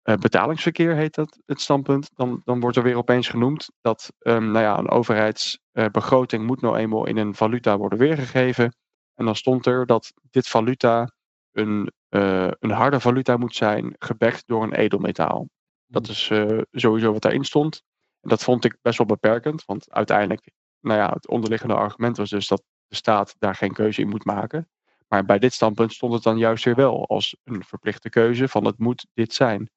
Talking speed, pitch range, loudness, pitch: 195 wpm, 110-125 Hz, -21 LUFS, 115 Hz